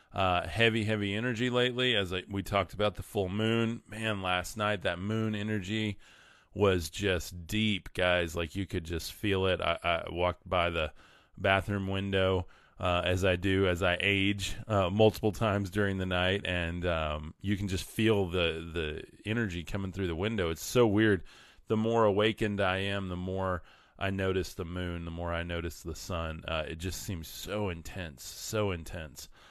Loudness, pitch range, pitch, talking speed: -31 LUFS, 90-105 Hz, 95 Hz, 185 wpm